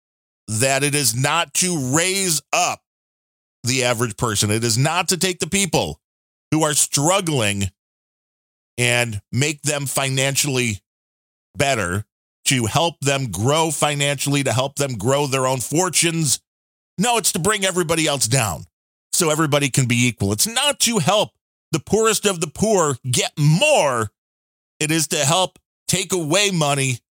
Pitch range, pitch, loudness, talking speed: 120-170 Hz, 140 Hz, -19 LUFS, 150 wpm